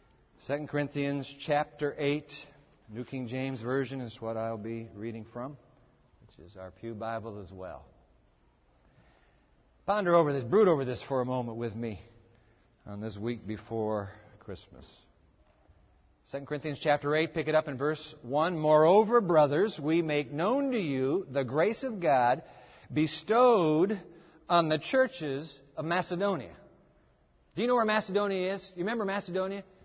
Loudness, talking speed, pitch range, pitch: -30 LUFS, 145 wpm, 115-170 Hz, 145 Hz